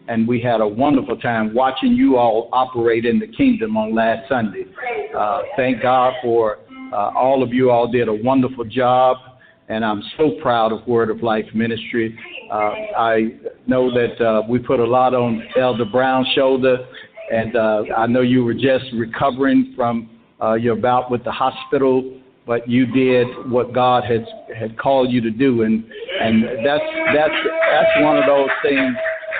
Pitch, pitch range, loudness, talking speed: 125 Hz, 115-130 Hz, -17 LUFS, 175 wpm